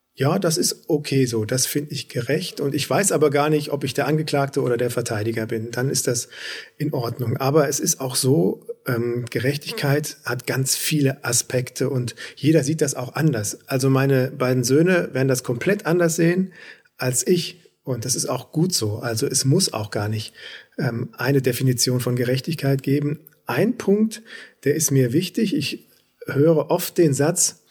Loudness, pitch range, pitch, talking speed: -21 LUFS, 125-155 Hz, 140 Hz, 180 wpm